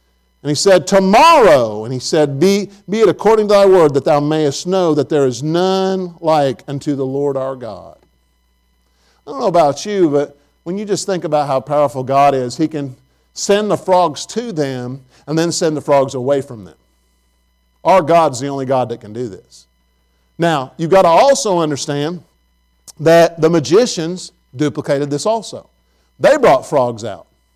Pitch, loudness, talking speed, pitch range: 145 Hz, -14 LUFS, 180 wpm, 125-170 Hz